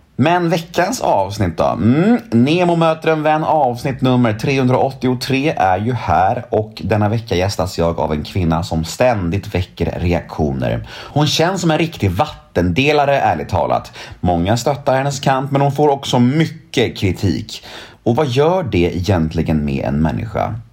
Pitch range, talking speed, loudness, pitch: 90-145 Hz, 155 wpm, -16 LUFS, 120 Hz